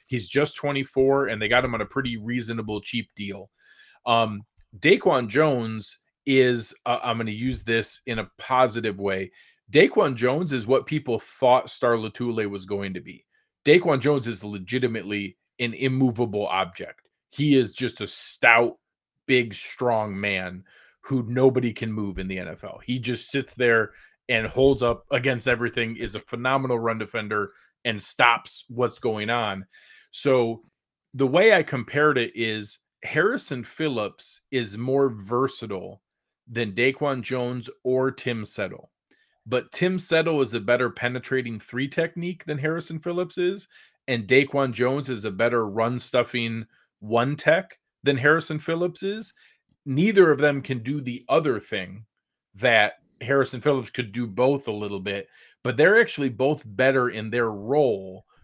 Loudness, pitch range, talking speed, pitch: -24 LUFS, 110-135 Hz, 155 wpm, 125 Hz